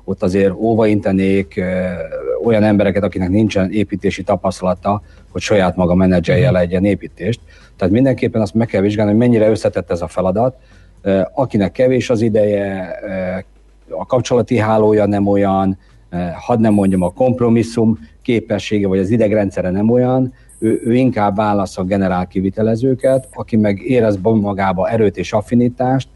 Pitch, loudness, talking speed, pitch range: 105 Hz, -15 LUFS, 140 wpm, 95-115 Hz